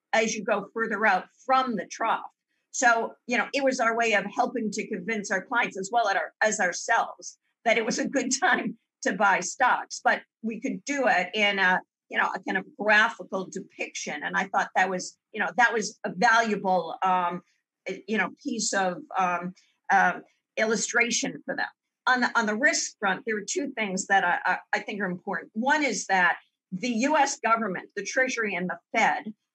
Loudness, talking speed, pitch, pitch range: -26 LUFS, 200 wpm, 225 Hz, 195-245 Hz